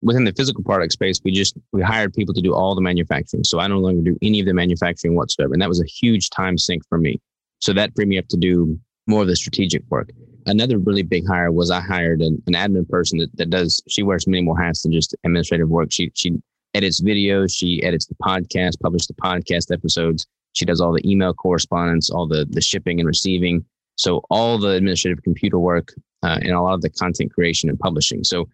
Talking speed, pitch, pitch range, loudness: 230 wpm, 90 Hz, 85-100 Hz, -19 LUFS